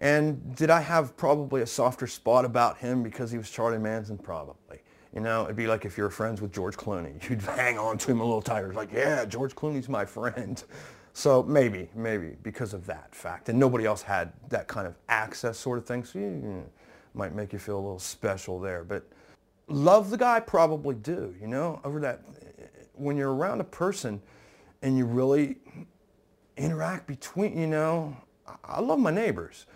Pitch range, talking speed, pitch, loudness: 110-145 Hz, 200 wpm, 125 Hz, -28 LUFS